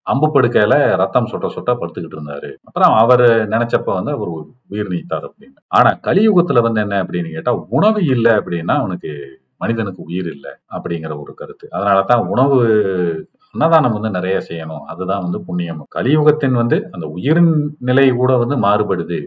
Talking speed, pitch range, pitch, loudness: 150 wpm, 90-130 Hz, 110 Hz, -16 LUFS